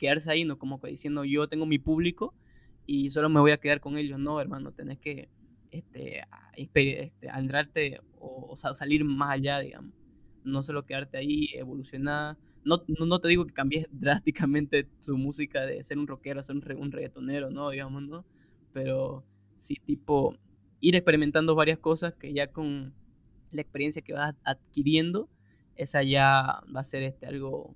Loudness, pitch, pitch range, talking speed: -29 LUFS, 145 Hz, 135-150 Hz, 175 wpm